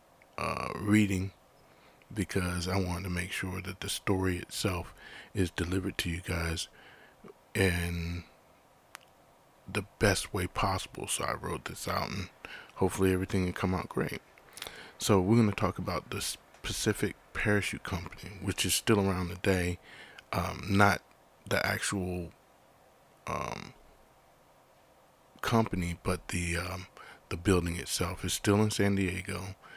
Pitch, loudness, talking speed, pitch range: 95 Hz, -32 LUFS, 130 wpm, 90-100 Hz